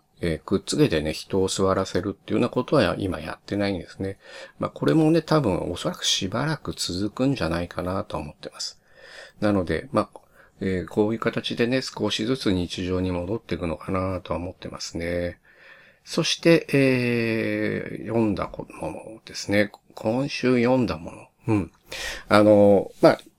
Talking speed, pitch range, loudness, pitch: 330 characters per minute, 95-120 Hz, -24 LUFS, 105 Hz